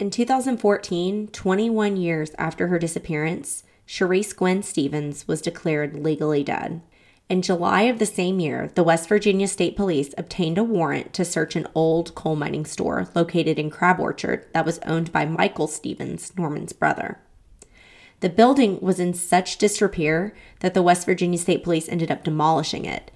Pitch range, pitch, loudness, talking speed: 160-195 Hz, 175 Hz, -22 LUFS, 165 wpm